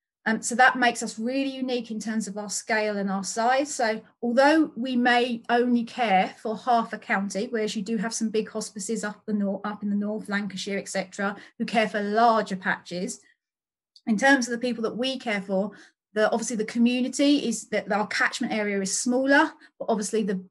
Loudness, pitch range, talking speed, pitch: -25 LUFS, 210-240 Hz, 205 wpm, 220 Hz